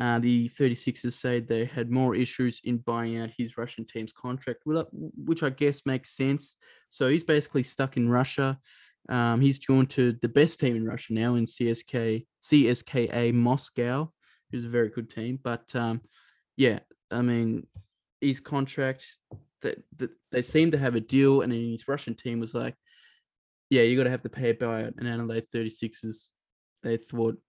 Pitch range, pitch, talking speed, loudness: 115-135 Hz, 120 Hz, 175 wpm, -28 LUFS